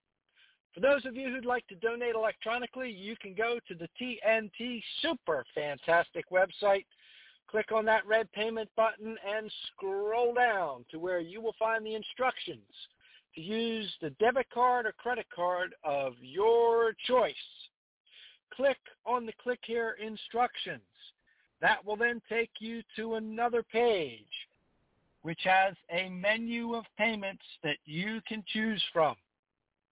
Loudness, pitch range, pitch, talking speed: -32 LUFS, 195-235 Hz, 220 Hz, 140 wpm